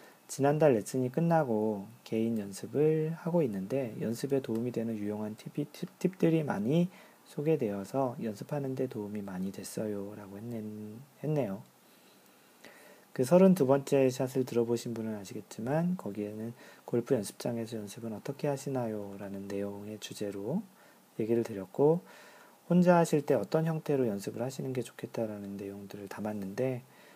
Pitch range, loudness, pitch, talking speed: 105-150 Hz, -32 LUFS, 120 Hz, 310 characters per minute